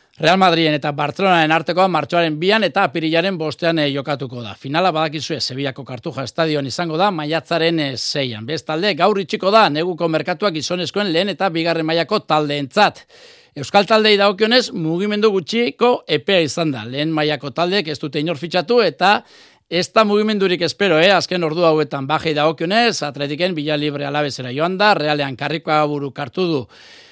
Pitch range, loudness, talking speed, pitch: 150-190 Hz, -17 LUFS, 160 wpm, 165 Hz